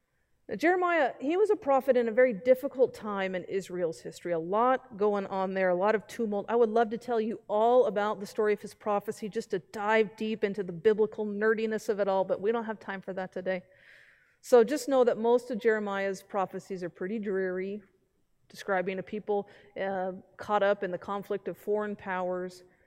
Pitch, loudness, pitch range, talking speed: 210 Hz, -29 LUFS, 190-230 Hz, 205 wpm